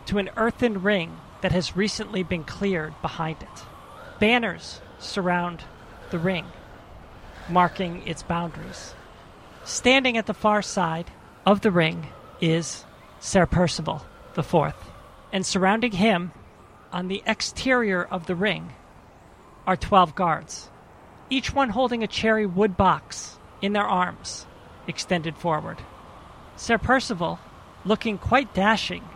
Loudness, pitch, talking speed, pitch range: -24 LUFS, 185 Hz, 125 wpm, 165-215 Hz